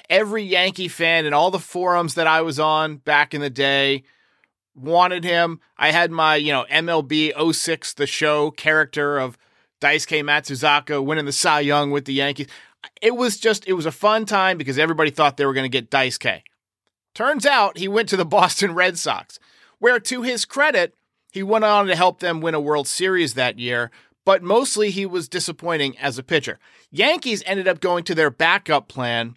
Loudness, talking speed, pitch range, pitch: -19 LUFS, 200 wpm, 145-190 Hz, 160 Hz